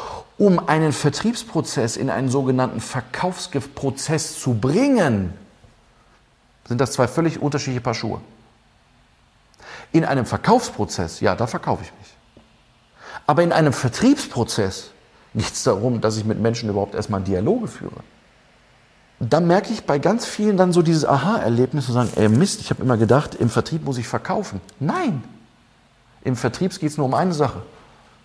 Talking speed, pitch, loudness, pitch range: 150 wpm, 130 Hz, -20 LUFS, 115-160 Hz